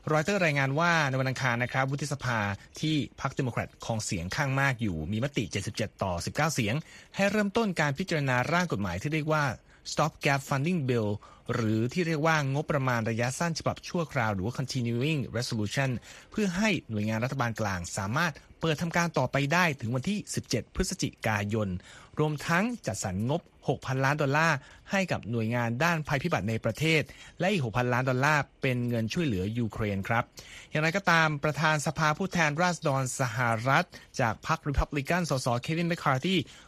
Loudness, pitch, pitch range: -29 LUFS, 140 Hz, 115-160 Hz